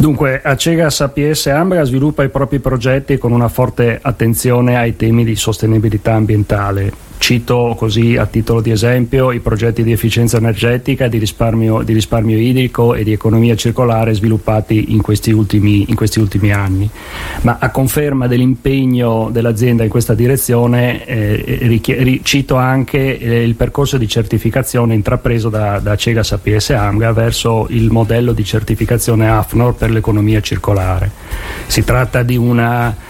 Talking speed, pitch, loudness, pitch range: 150 wpm, 115 Hz, -13 LUFS, 110-125 Hz